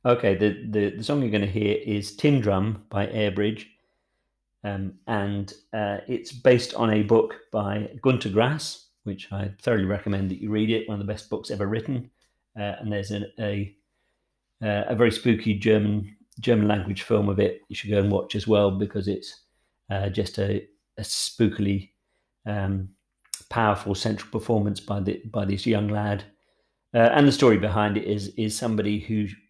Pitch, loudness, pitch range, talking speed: 105 Hz, -25 LUFS, 100-110 Hz, 180 wpm